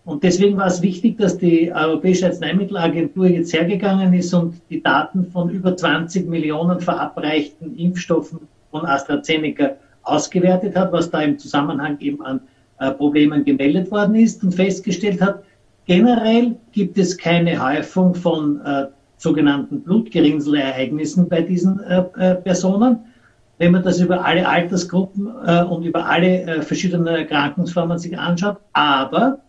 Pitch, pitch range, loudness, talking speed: 175 Hz, 155-185 Hz, -18 LUFS, 140 wpm